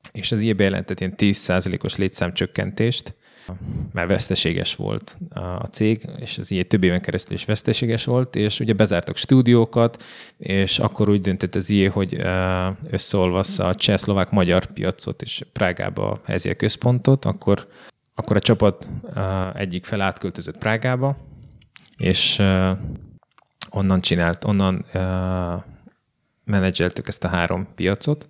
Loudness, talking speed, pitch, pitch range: -21 LUFS, 125 wpm, 100 Hz, 95-110 Hz